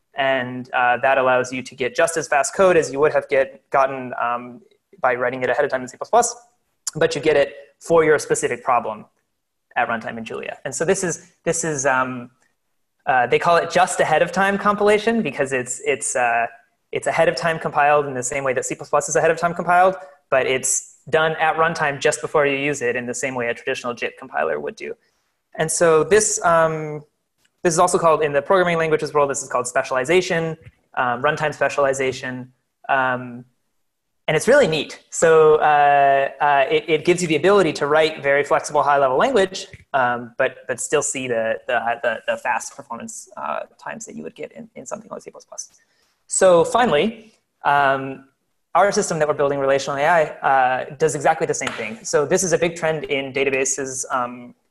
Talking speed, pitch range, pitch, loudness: 200 wpm, 130-175 Hz, 150 Hz, -19 LUFS